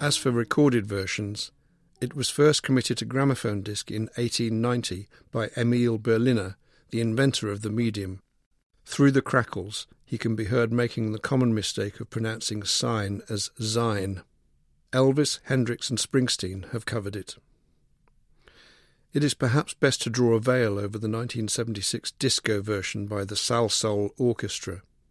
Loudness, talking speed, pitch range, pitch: -26 LUFS, 155 wpm, 105-125 Hz, 115 Hz